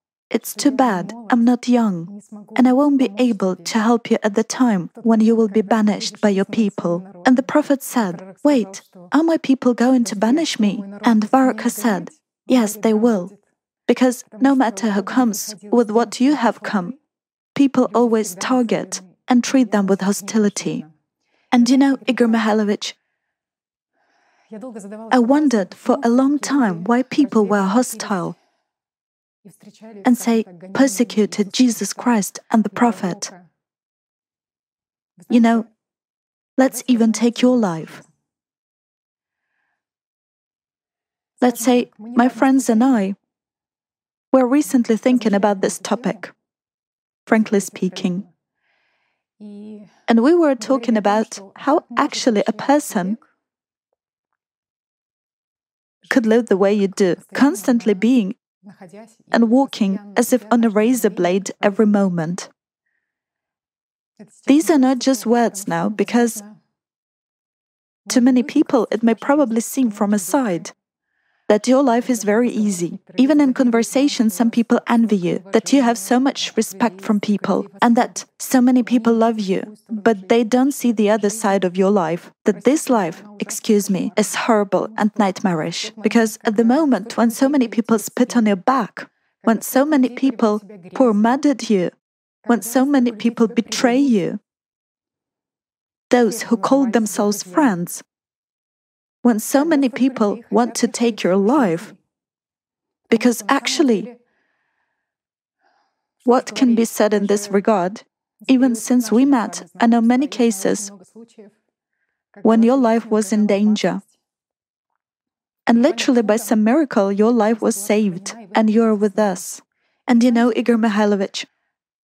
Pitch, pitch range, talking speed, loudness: 230 Hz, 210-255 Hz, 135 wpm, -18 LUFS